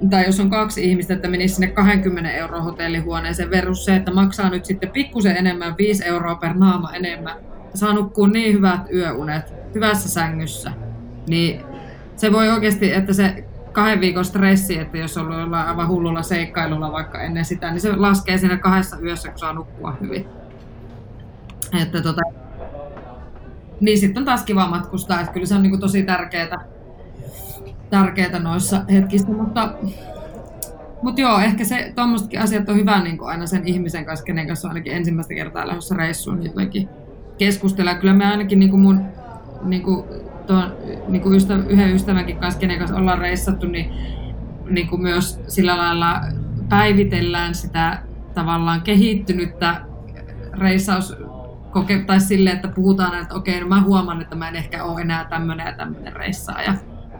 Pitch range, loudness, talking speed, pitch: 165-195 Hz, -19 LUFS, 155 wpm, 180 Hz